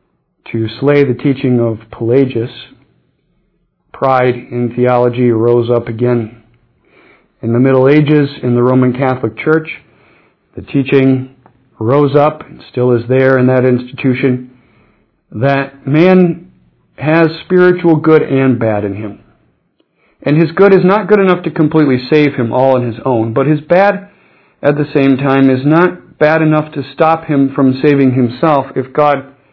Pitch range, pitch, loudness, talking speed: 125-150 Hz, 135 Hz, -11 LUFS, 150 wpm